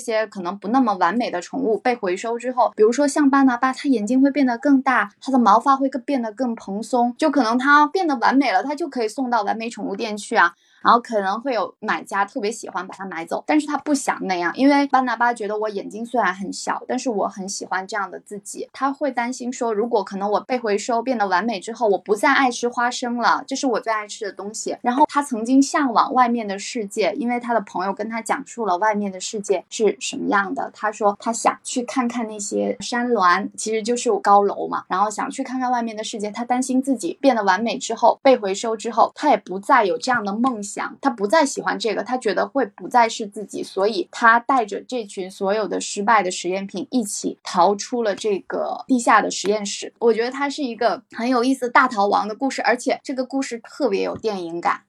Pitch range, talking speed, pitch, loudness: 205-265 Hz, 340 characters per minute, 235 Hz, -21 LUFS